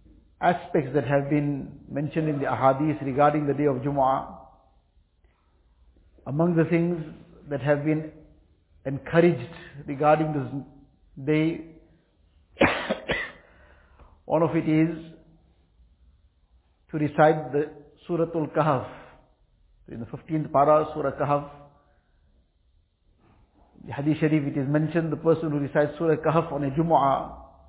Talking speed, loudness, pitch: 115 wpm, -25 LUFS, 145 Hz